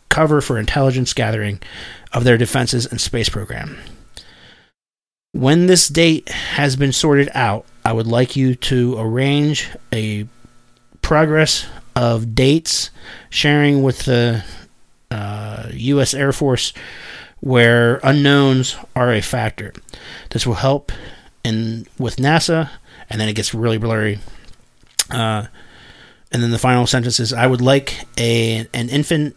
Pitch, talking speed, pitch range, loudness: 120 Hz, 130 wpm, 115-135 Hz, -16 LUFS